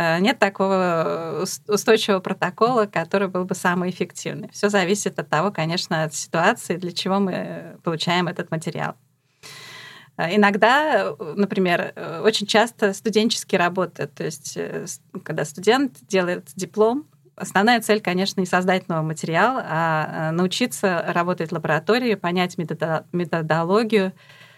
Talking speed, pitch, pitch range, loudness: 115 wpm, 185 Hz, 165-205 Hz, -21 LUFS